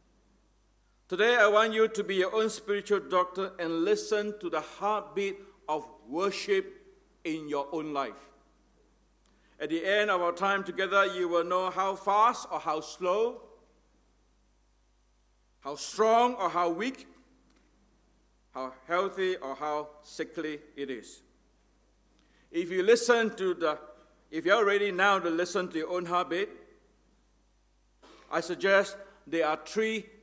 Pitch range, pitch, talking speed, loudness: 155-210 Hz, 190 Hz, 135 wpm, -29 LUFS